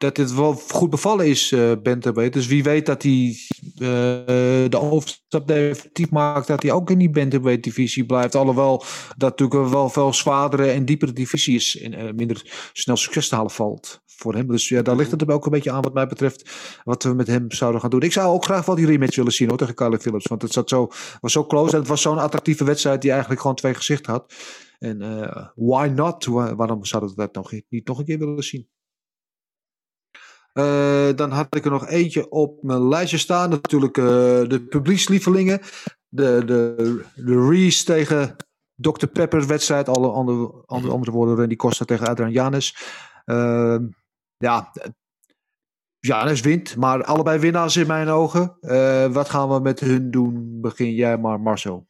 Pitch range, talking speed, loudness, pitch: 120-150 Hz, 190 wpm, -20 LUFS, 135 Hz